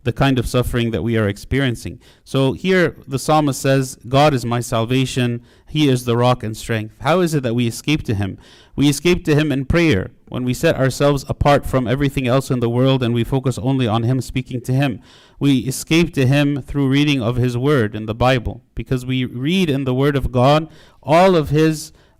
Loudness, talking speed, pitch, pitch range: -18 LUFS, 215 wpm, 130 Hz, 120-145 Hz